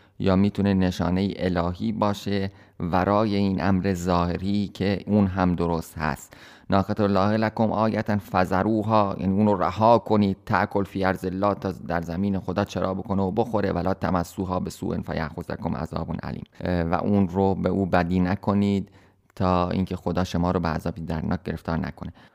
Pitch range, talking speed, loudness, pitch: 90-100 Hz, 165 wpm, -24 LUFS, 95 Hz